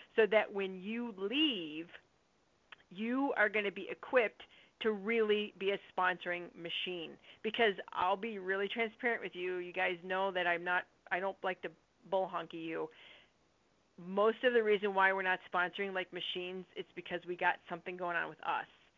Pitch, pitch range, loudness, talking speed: 190 Hz, 180-215 Hz, -35 LUFS, 175 wpm